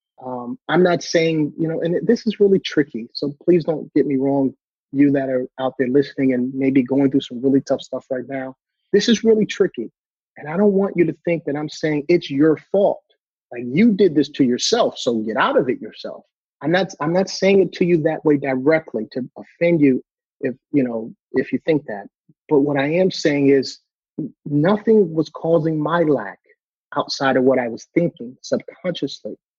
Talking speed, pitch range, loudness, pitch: 205 wpm, 130-170 Hz, -19 LUFS, 145 Hz